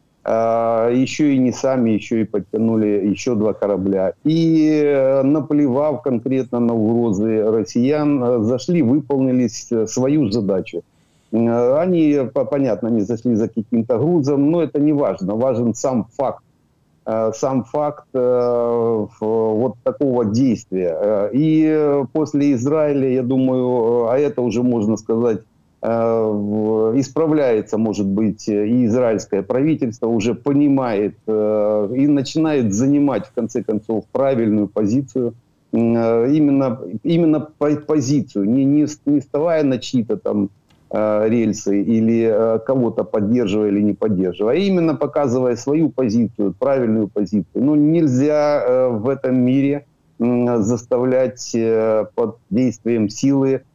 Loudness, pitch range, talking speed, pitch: -18 LUFS, 110-145 Hz, 110 wpm, 125 Hz